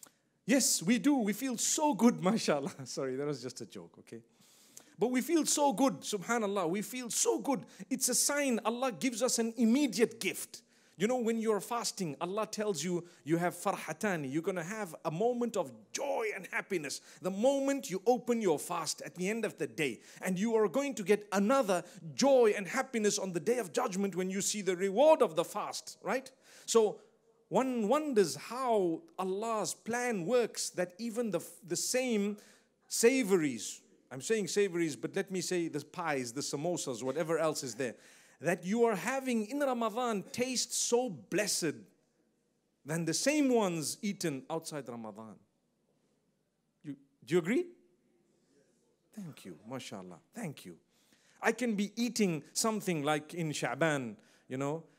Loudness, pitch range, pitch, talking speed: -33 LUFS, 170-245 Hz, 210 Hz, 170 wpm